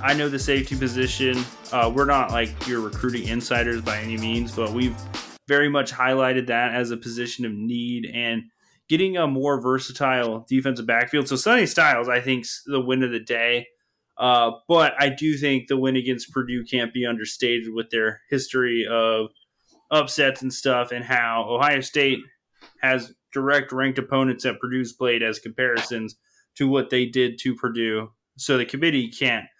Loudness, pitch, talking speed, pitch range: -22 LUFS, 125 Hz, 170 wpm, 115-135 Hz